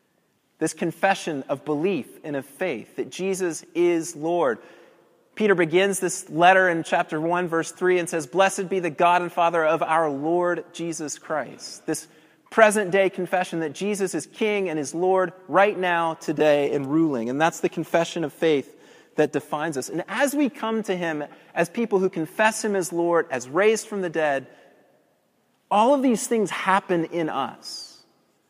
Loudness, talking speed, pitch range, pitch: -23 LUFS, 175 wpm, 160-190 Hz, 170 Hz